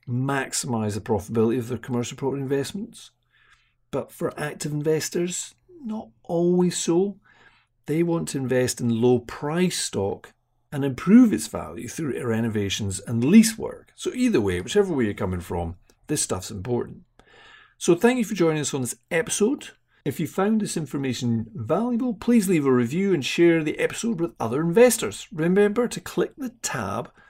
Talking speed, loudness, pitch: 165 wpm, -24 LUFS, 155 Hz